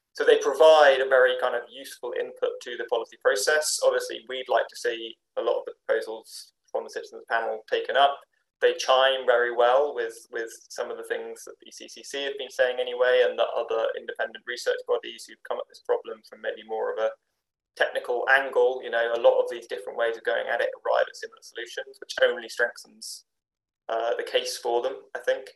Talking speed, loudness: 210 wpm, -25 LUFS